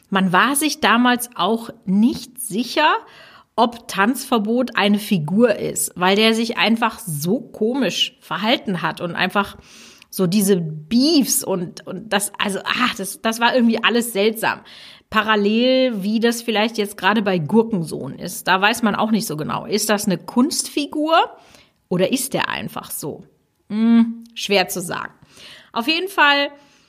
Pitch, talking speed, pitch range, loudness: 225 Hz, 150 wpm, 195-245 Hz, -19 LUFS